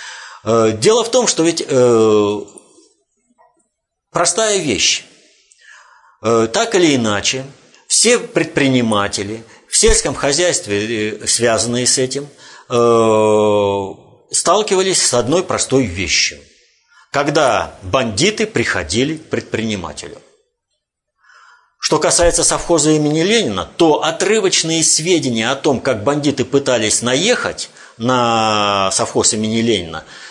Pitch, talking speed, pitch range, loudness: 130 Hz, 95 wpm, 110-170 Hz, -14 LUFS